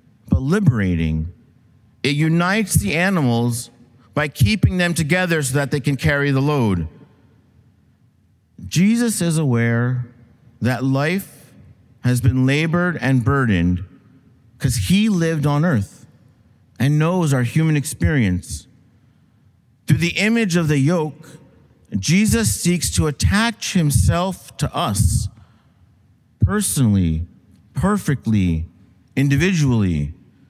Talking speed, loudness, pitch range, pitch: 105 wpm, -19 LUFS, 115-160 Hz, 130 Hz